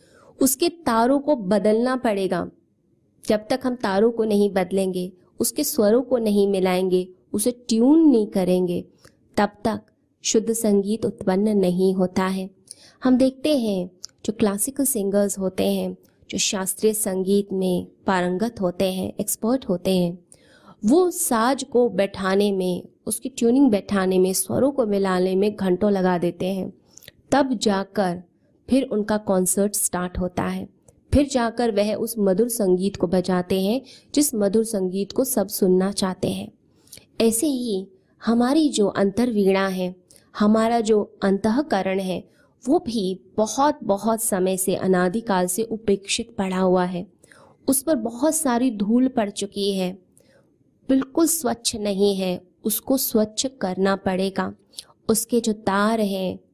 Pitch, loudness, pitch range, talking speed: 205 Hz, -22 LUFS, 190-235 Hz, 140 wpm